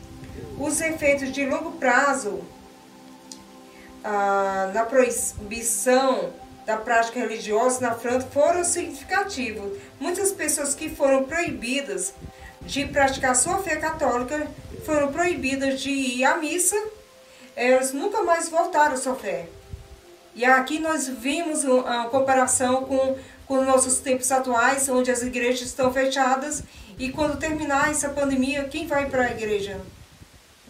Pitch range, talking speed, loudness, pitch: 245-295 Hz, 125 wpm, -23 LUFS, 265 Hz